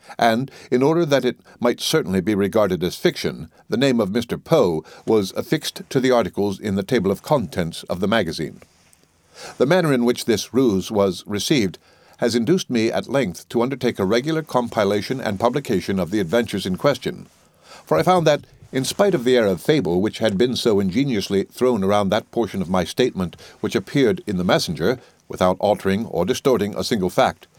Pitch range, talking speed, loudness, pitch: 100-135 Hz, 195 wpm, -20 LUFS, 120 Hz